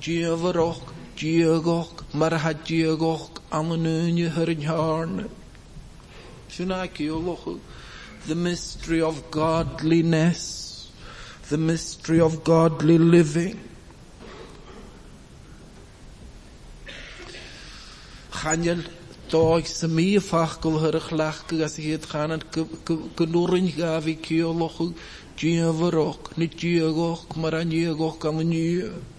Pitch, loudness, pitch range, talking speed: 165 Hz, -24 LUFS, 160-165 Hz, 90 wpm